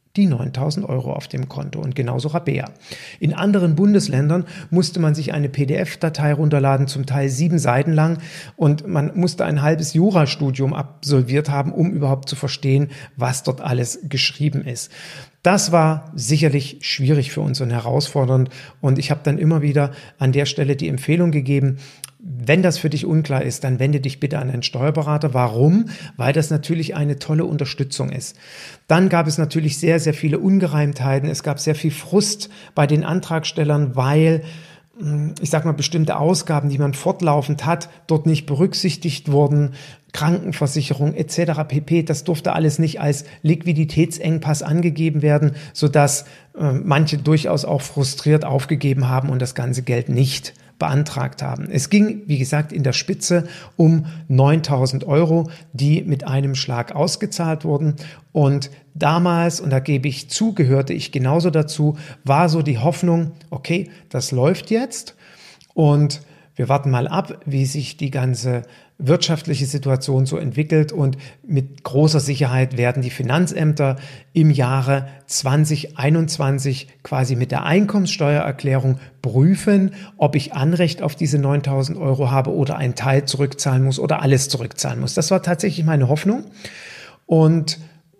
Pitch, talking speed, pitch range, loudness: 150 Hz, 150 wpm, 140-160 Hz, -19 LUFS